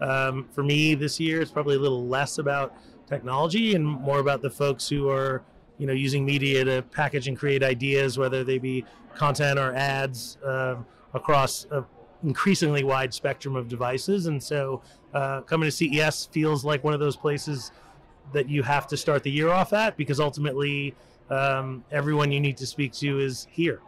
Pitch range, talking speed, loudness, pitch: 135-150 Hz, 185 wpm, -26 LUFS, 140 Hz